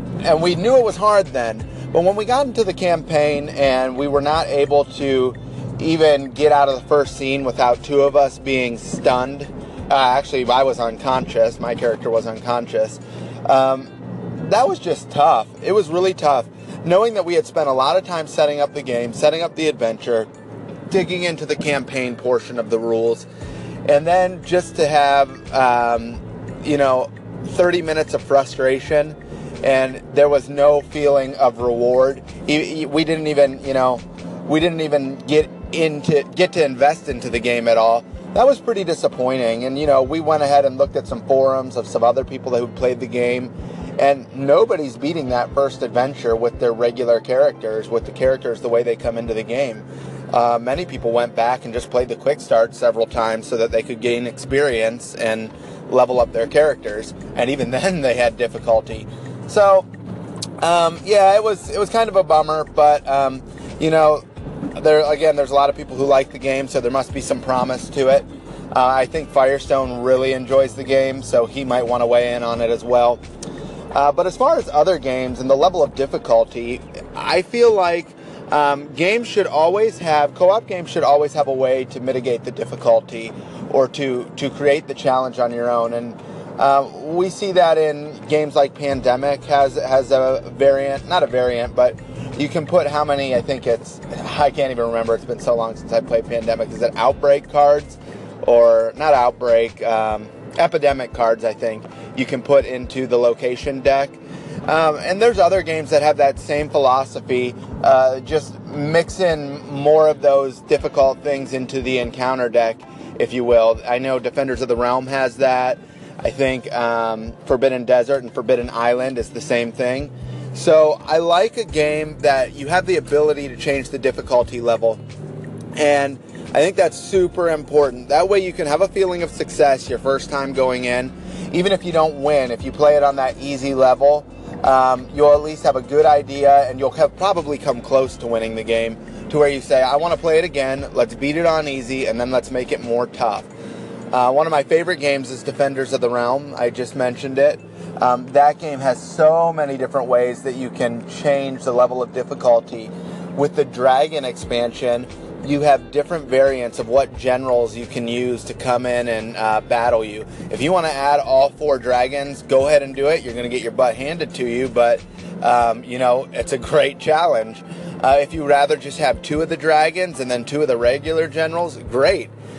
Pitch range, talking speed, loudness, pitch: 120-150 Hz, 200 wpm, -18 LUFS, 135 Hz